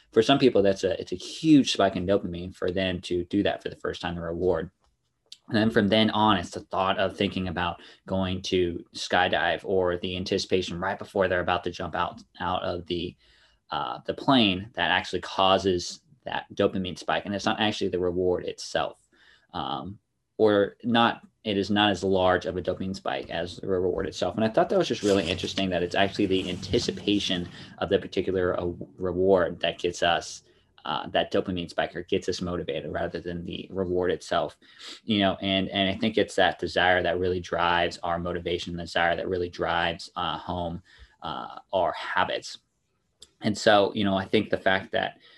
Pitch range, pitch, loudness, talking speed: 90-100 Hz, 95 Hz, -26 LUFS, 195 wpm